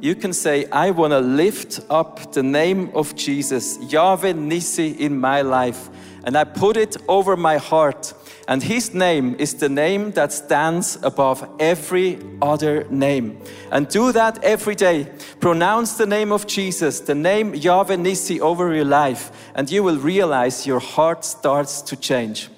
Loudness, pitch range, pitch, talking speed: -19 LUFS, 140-185 Hz, 155 Hz, 165 wpm